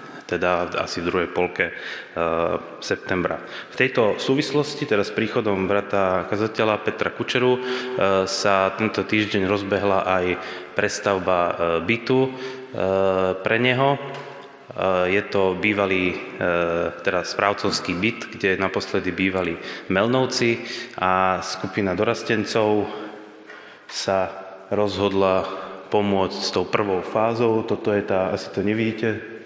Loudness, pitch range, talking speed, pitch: -22 LUFS, 95-115 Hz, 115 wpm, 100 Hz